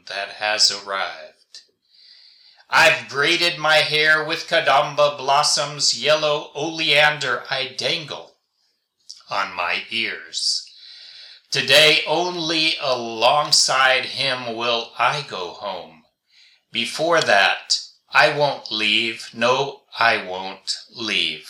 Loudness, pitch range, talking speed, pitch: -18 LUFS, 115-155 Hz, 95 wpm, 145 Hz